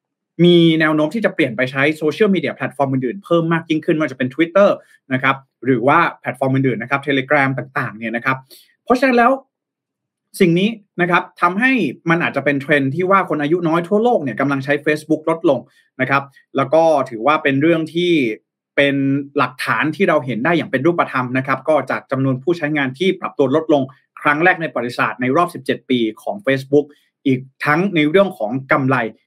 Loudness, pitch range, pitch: -17 LUFS, 135-175 Hz, 150 Hz